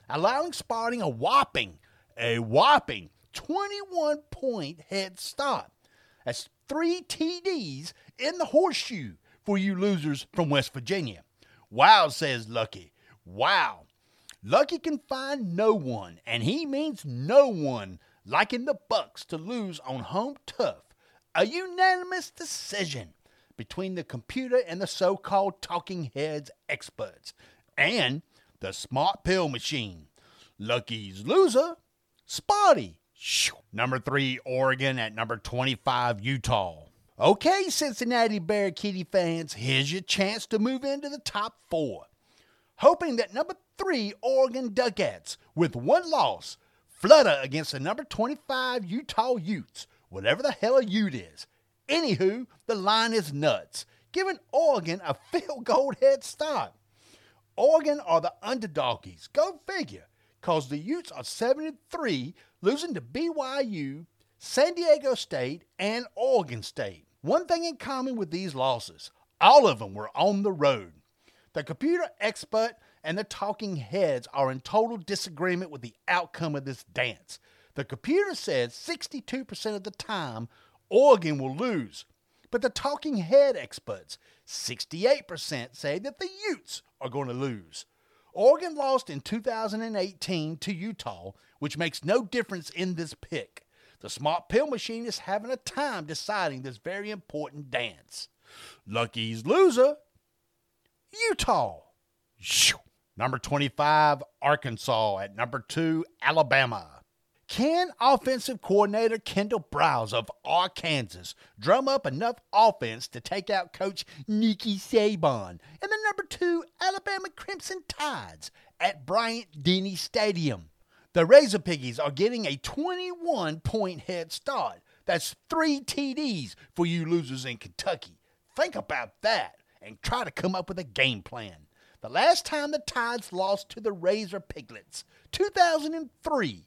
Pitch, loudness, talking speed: 200 Hz, -27 LUFS, 130 wpm